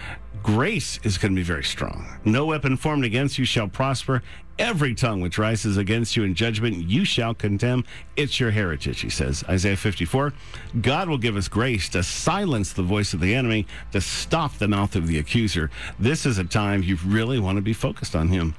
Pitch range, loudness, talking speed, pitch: 95-125 Hz, -23 LUFS, 205 wpm, 105 Hz